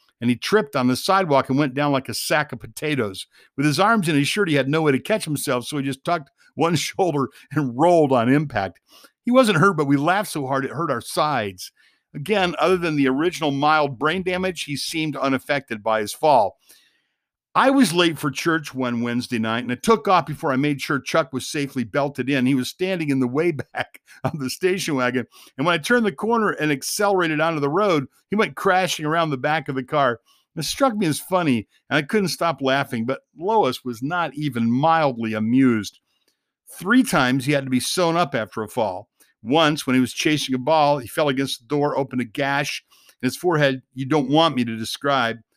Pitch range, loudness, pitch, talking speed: 130-170 Hz, -21 LUFS, 145 Hz, 220 wpm